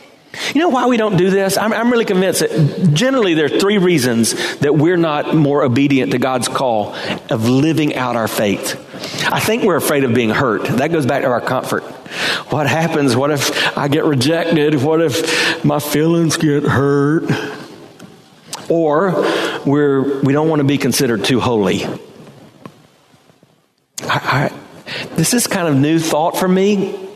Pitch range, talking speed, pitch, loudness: 140-175 Hz, 170 wpm, 155 Hz, -15 LUFS